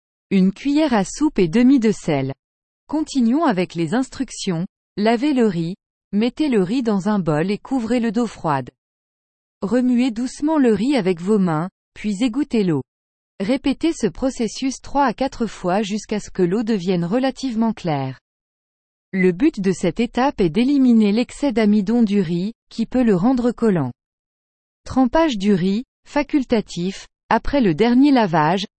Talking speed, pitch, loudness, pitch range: 155 wpm, 220 Hz, -19 LUFS, 185-260 Hz